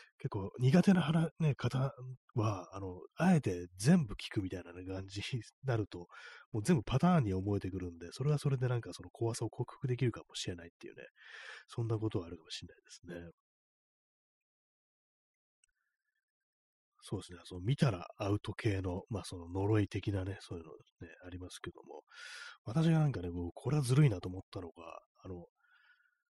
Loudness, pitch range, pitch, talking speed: -35 LUFS, 95-150 Hz, 110 Hz, 345 characters per minute